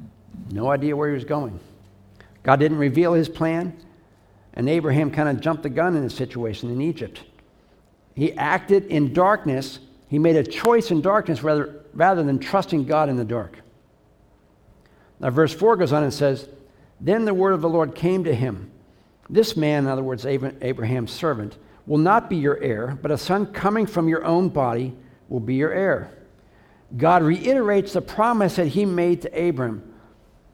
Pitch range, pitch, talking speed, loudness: 120-170 Hz, 145 Hz, 175 wpm, -21 LUFS